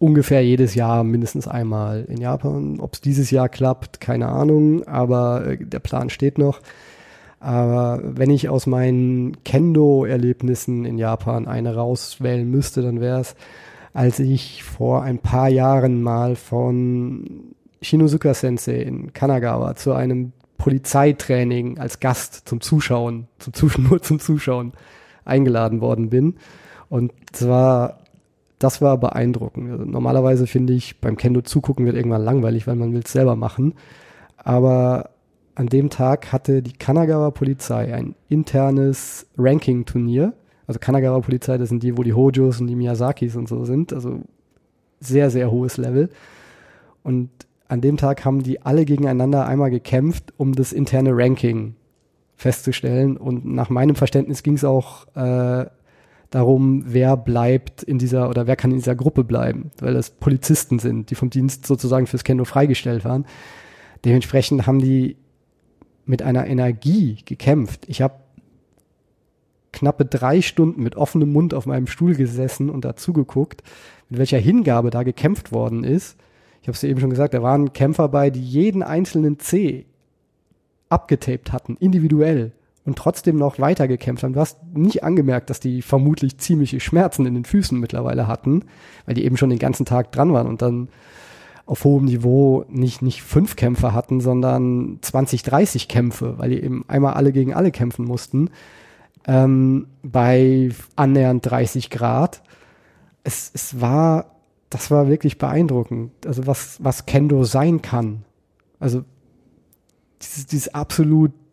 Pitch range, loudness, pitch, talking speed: 125-140 Hz, -19 LUFS, 130 Hz, 150 wpm